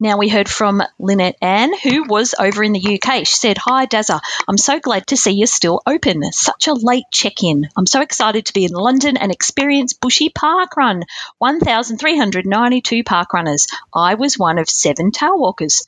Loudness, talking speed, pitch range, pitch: -14 LUFS, 190 wpm, 195-265 Hz, 220 Hz